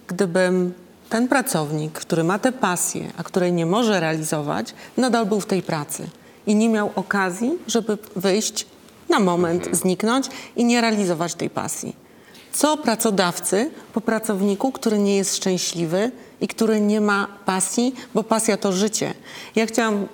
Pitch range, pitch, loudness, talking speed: 185-225 Hz, 205 Hz, -21 LUFS, 150 wpm